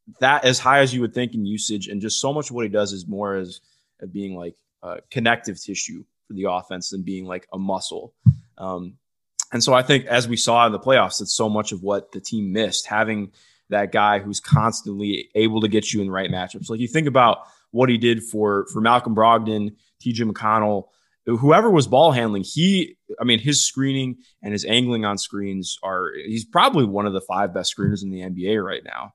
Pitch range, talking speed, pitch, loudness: 100-120 Hz, 220 wpm, 110 Hz, -21 LUFS